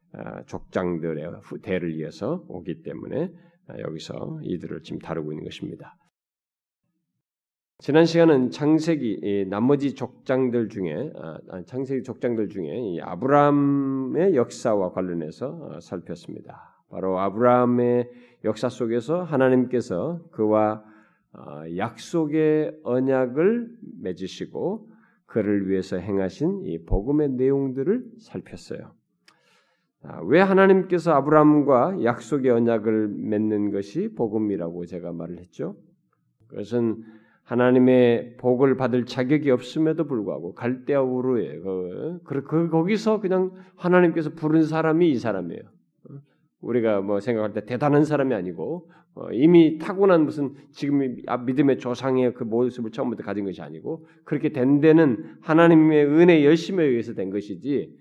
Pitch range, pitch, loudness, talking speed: 110-160 Hz, 130 Hz, -22 LUFS, 285 characters per minute